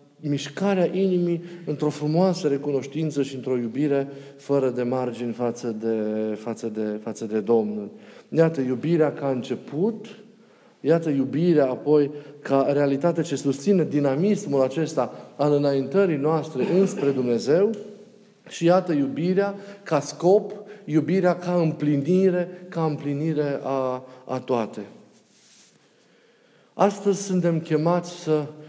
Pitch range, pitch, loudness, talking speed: 135-180 Hz, 150 Hz, -24 LUFS, 115 wpm